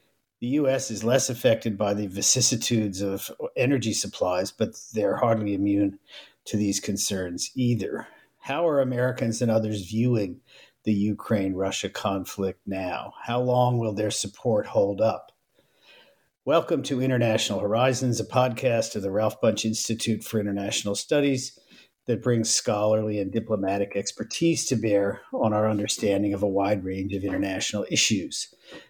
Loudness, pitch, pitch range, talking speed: -25 LUFS, 110 Hz, 100-120 Hz, 145 wpm